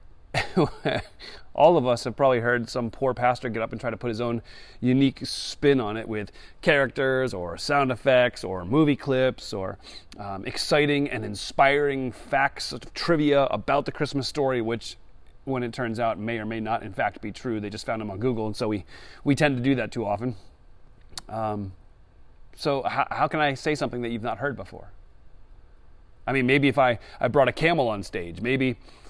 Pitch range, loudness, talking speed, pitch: 105-135 Hz, -25 LUFS, 195 wpm, 120 Hz